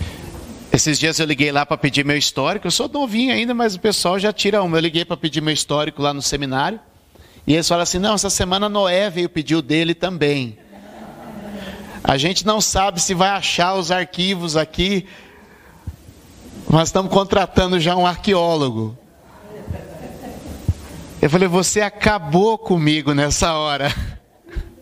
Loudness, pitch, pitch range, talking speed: -18 LUFS, 175 Hz, 150-195 Hz, 155 wpm